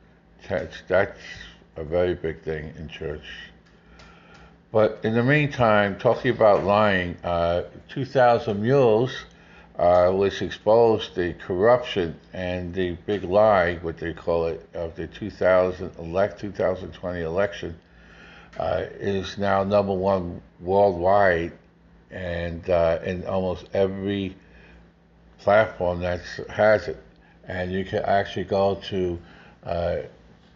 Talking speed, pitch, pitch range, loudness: 115 wpm, 95 Hz, 85-100 Hz, -23 LUFS